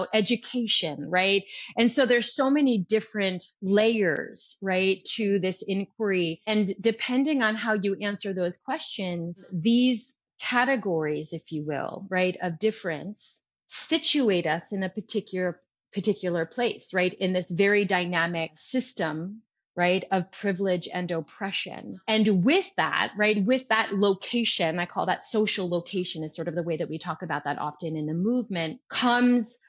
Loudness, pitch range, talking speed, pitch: -26 LUFS, 175-220 Hz, 150 wpm, 195 Hz